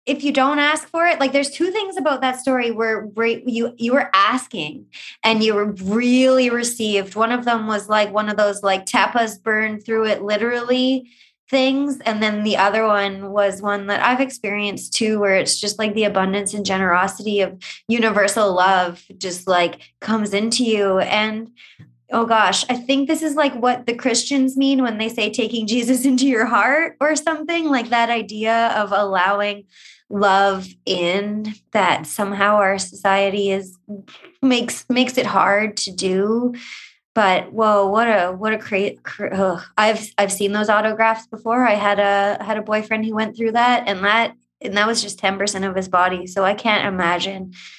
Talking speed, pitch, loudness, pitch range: 180 wpm, 215 Hz, -18 LUFS, 200-245 Hz